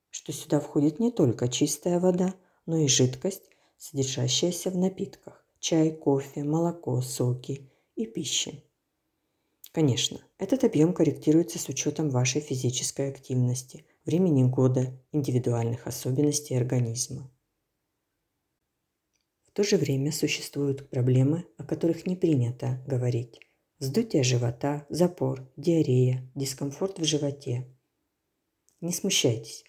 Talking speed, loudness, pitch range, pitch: 105 wpm, -27 LUFS, 130-165 Hz, 145 Hz